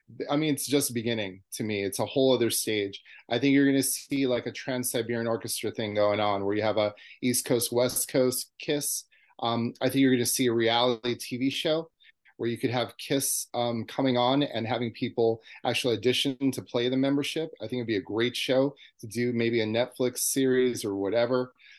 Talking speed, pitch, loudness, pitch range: 215 wpm, 125 Hz, -27 LUFS, 115-135 Hz